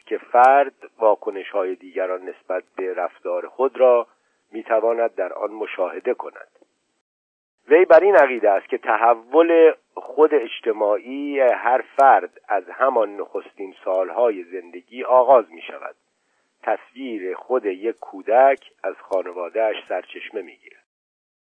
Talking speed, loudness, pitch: 125 wpm, -19 LUFS, 165 Hz